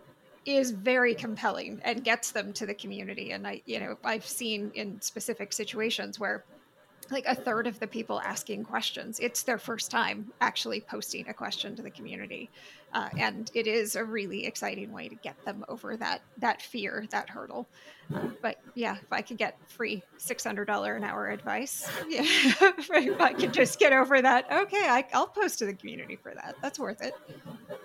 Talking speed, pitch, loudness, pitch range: 190 wpm, 230 Hz, -29 LUFS, 215-255 Hz